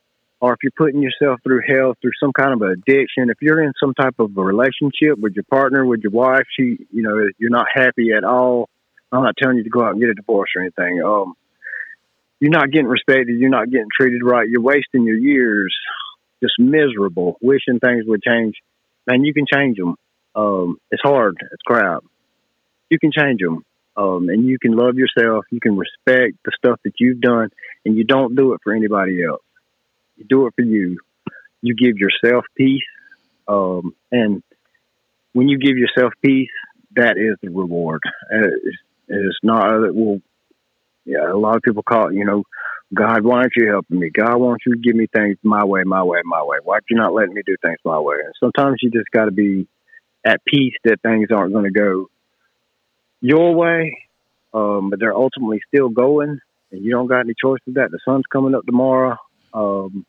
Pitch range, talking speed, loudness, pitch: 105-135 Hz, 205 wpm, -16 LUFS, 120 Hz